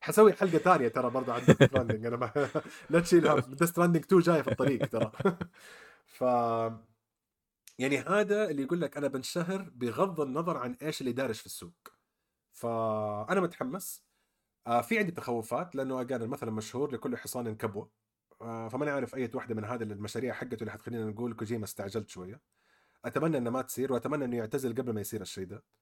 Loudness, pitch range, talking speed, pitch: -31 LUFS, 115-150 Hz, 165 wpm, 125 Hz